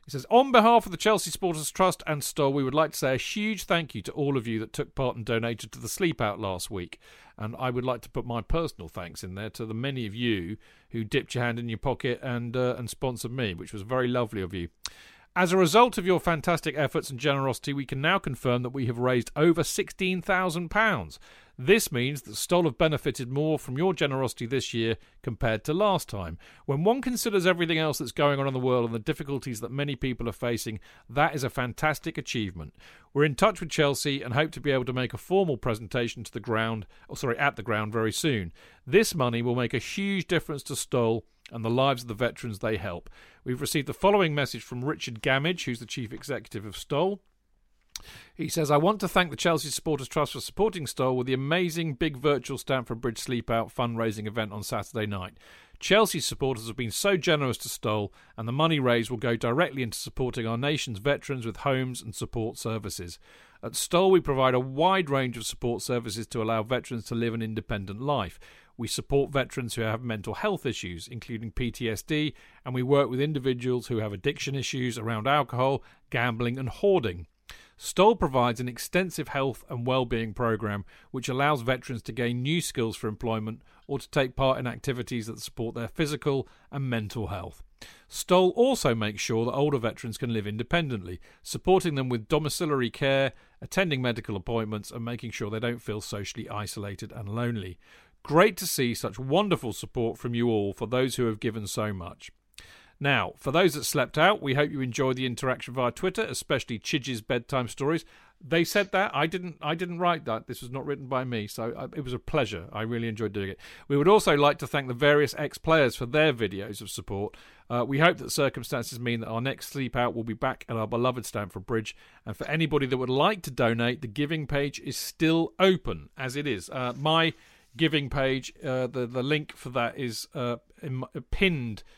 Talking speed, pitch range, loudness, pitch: 210 wpm, 115-150 Hz, -28 LUFS, 130 Hz